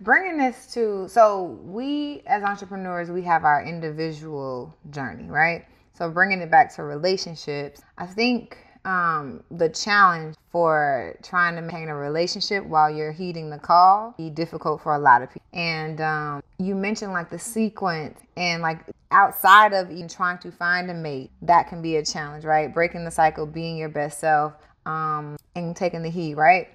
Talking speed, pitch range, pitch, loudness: 175 wpm, 155-190 Hz, 170 Hz, -22 LUFS